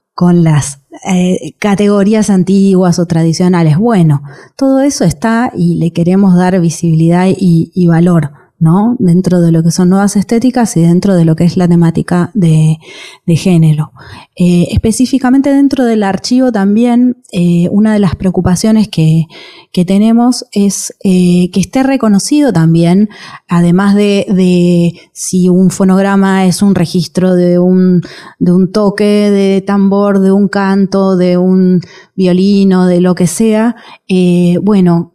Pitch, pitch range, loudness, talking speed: 185 Hz, 175-200 Hz, -9 LUFS, 145 wpm